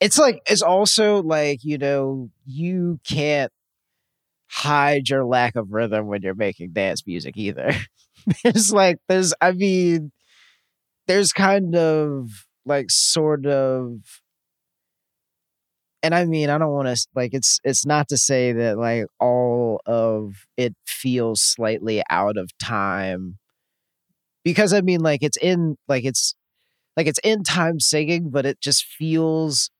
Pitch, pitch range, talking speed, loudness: 145 Hz, 120-170 Hz, 145 wpm, -20 LUFS